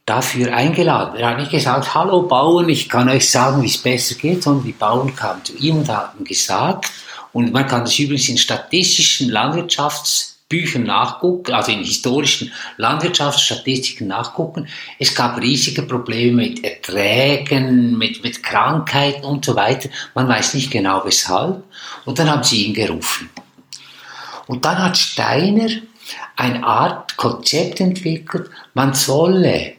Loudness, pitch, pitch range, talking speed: -16 LUFS, 135 Hz, 120-155 Hz, 145 wpm